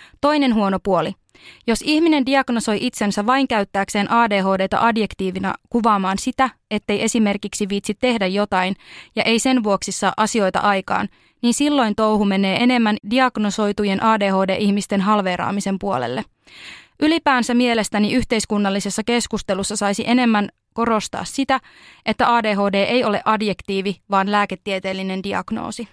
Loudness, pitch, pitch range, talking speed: -19 LUFS, 210 Hz, 200-235 Hz, 115 wpm